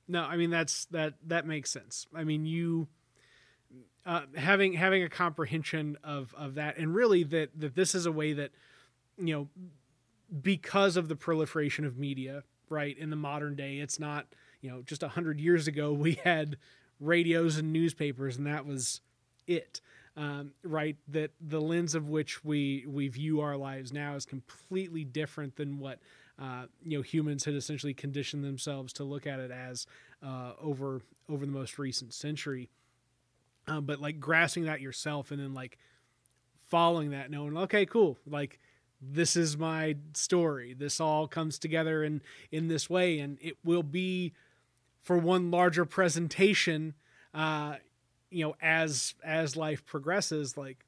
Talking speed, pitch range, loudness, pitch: 165 wpm, 140-165 Hz, -32 LUFS, 150 Hz